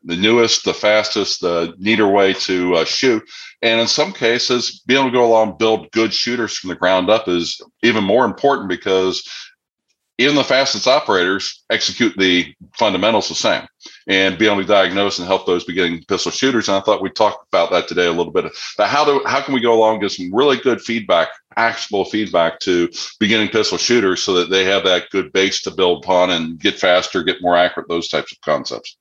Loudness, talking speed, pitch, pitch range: -16 LUFS, 215 wpm, 100 Hz, 90-115 Hz